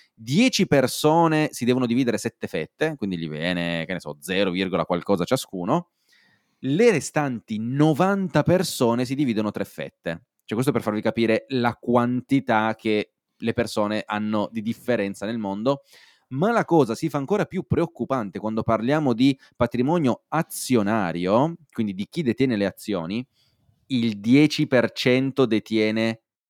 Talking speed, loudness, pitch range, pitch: 135 wpm, -23 LUFS, 110-145 Hz, 120 Hz